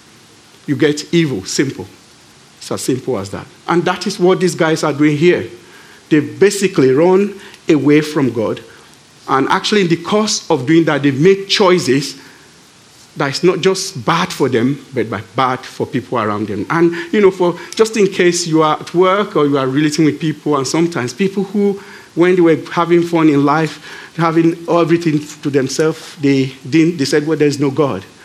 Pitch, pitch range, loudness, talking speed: 160 Hz, 145-180 Hz, -14 LUFS, 190 wpm